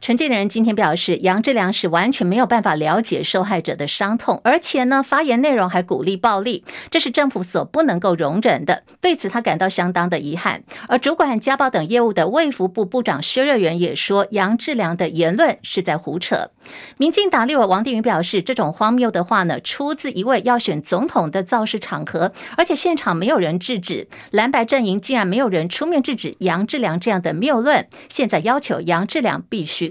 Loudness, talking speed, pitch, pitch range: -18 LUFS, 315 characters per minute, 225 Hz, 185-265 Hz